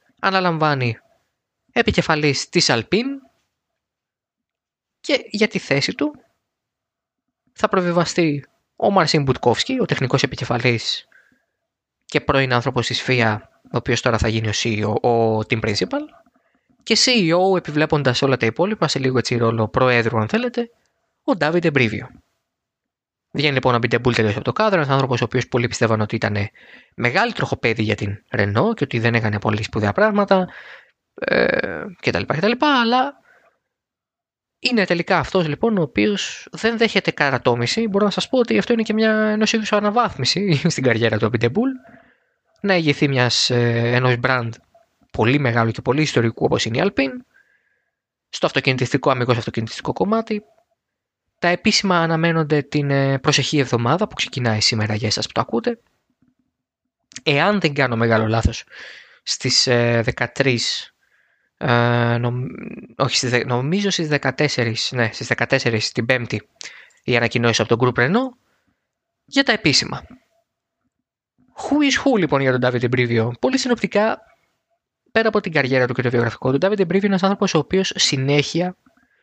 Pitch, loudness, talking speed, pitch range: 140 Hz, -19 LUFS, 140 wpm, 120-200 Hz